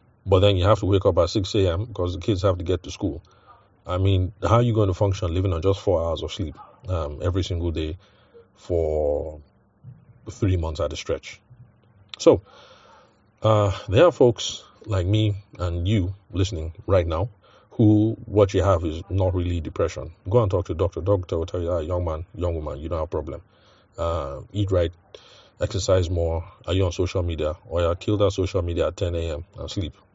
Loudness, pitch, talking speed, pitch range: -24 LUFS, 95 Hz, 205 wpm, 85-105 Hz